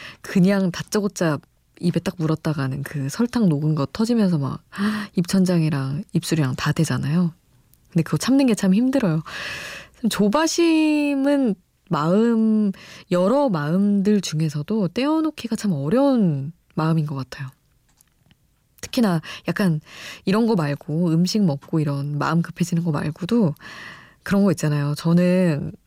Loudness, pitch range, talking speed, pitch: -21 LUFS, 155-215 Hz, 270 characters per minute, 175 Hz